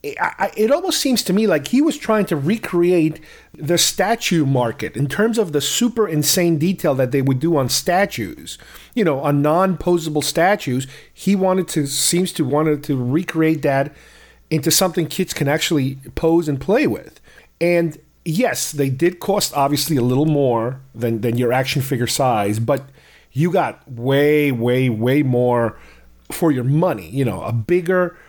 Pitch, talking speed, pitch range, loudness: 150 Hz, 170 wpm, 135-175 Hz, -18 LUFS